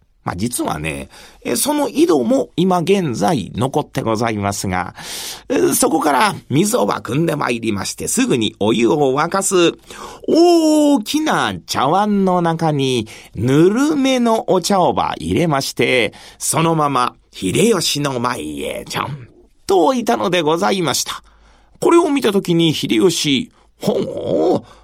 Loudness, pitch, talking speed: -16 LUFS, 170 Hz, 250 characters per minute